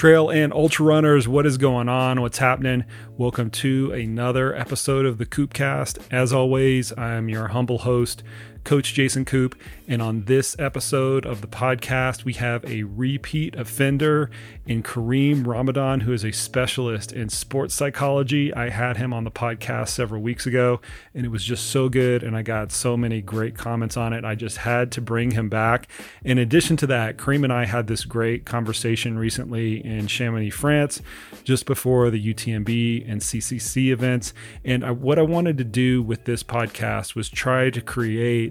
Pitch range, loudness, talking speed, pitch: 115-130 Hz, -22 LUFS, 180 wpm, 125 Hz